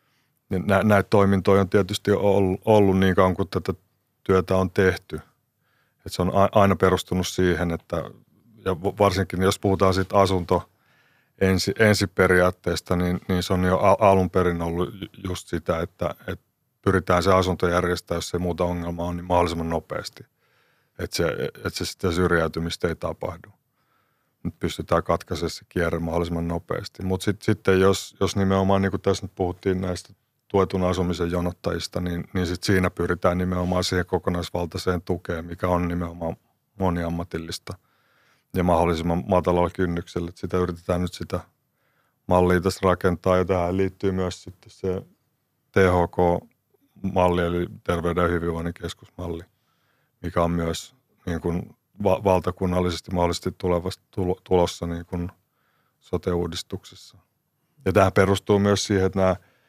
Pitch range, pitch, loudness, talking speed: 90-100 Hz, 95 Hz, -23 LUFS, 140 wpm